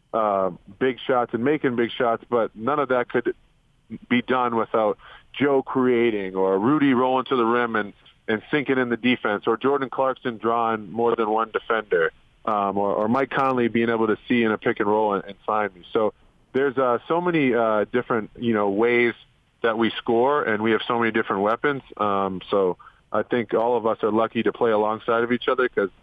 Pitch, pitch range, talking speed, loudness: 115 Hz, 110-130 Hz, 210 wpm, -23 LUFS